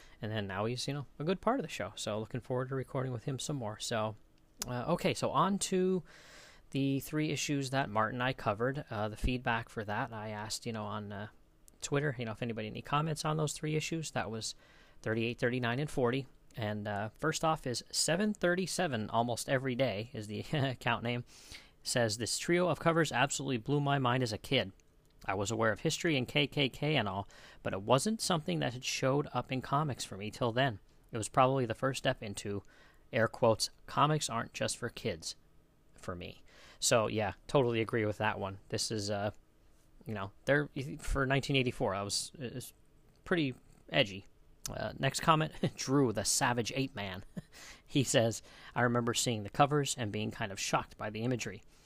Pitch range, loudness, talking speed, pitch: 110-145 Hz, -34 LUFS, 200 wpm, 125 Hz